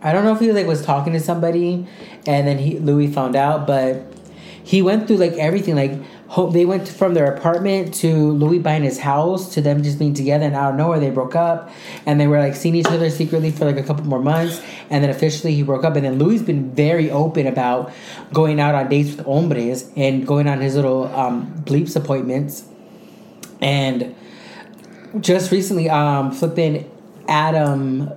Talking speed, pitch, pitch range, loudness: 200 wpm, 150 Hz, 140-170 Hz, -18 LUFS